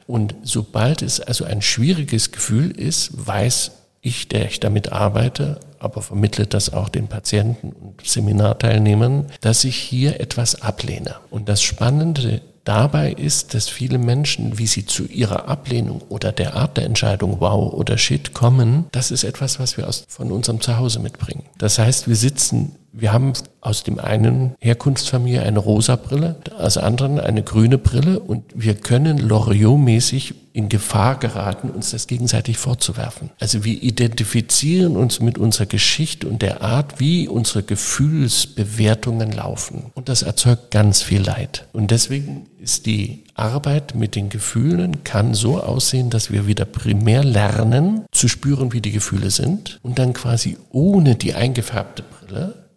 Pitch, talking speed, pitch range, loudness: 120 Hz, 155 wpm, 110-135 Hz, -18 LUFS